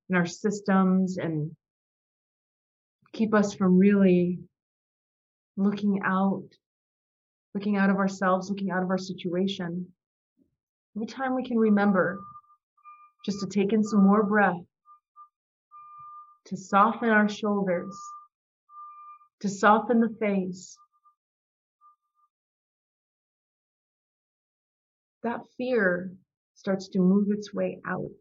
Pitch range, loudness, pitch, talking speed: 190-265 Hz, -25 LUFS, 205 Hz, 100 wpm